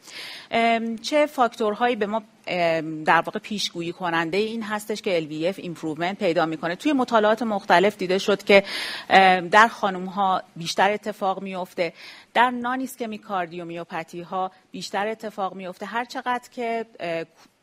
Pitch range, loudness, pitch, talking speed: 175-225 Hz, -23 LUFS, 200 Hz, 125 wpm